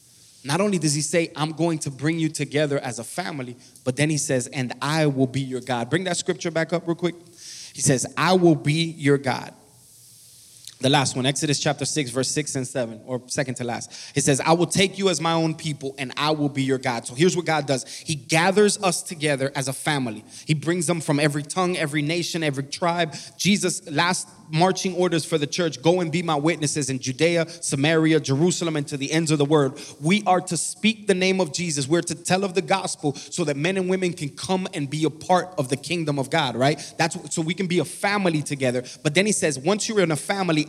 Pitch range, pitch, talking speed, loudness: 140-175 Hz, 155 Hz, 240 wpm, -23 LUFS